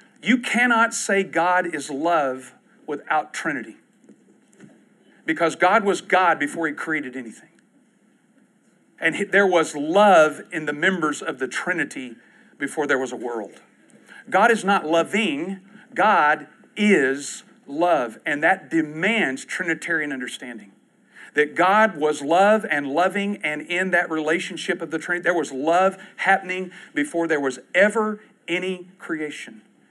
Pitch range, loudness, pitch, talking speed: 155-210 Hz, -21 LUFS, 180 Hz, 130 wpm